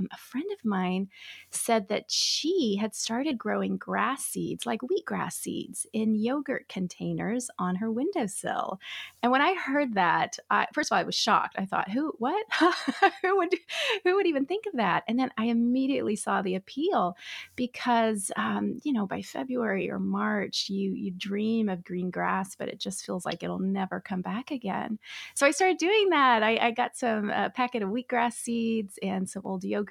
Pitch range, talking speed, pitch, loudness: 195-275 Hz, 190 wpm, 230 Hz, -28 LUFS